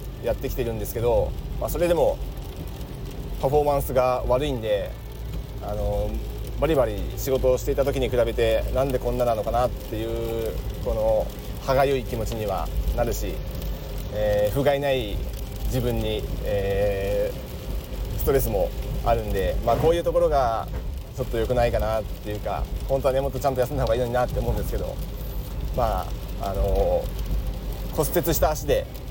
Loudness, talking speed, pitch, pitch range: -25 LUFS, 330 characters per minute, 115 Hz, 100-130 Hz